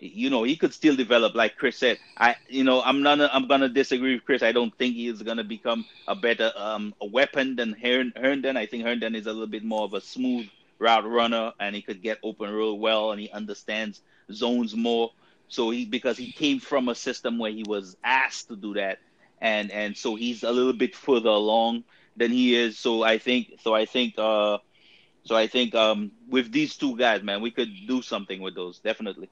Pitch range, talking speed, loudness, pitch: 110-125 Hz, 220 wpm, -25 LUFS, 115 Hz